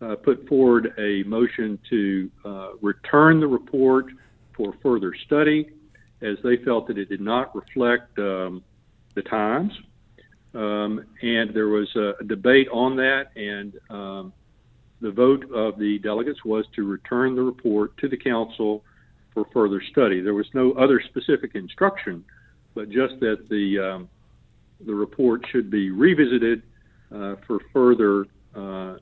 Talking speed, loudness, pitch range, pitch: 145 wpm, -22 LUFS, 105-125 Hz, 110 Hz